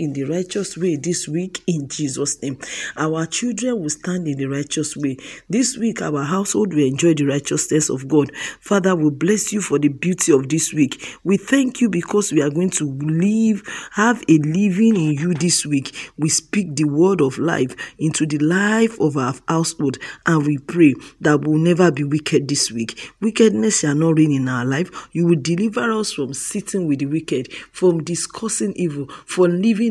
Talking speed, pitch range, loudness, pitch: 195 wpm, 145-195 Hz, -19 LUFS, 165 Hz